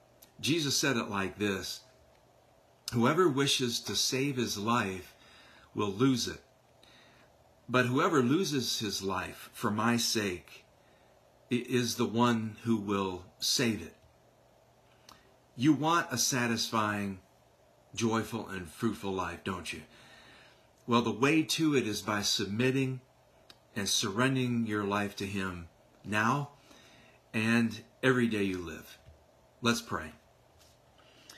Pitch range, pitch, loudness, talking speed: 100-125 Hz, 115 Hz, -31 LUFS, 115 wpm